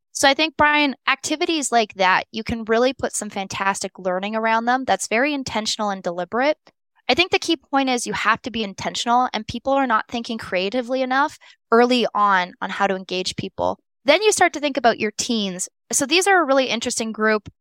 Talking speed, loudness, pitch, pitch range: 210 wpm, -20 LUFS, 235 Hz, 205-275 Hz